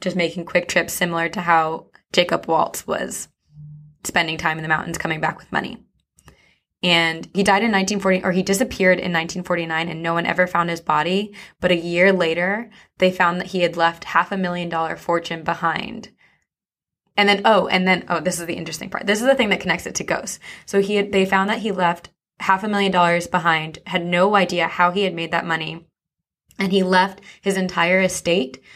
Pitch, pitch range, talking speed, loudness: 175 Hz, 165-190 Hz, 210 wpm, -20 LUFS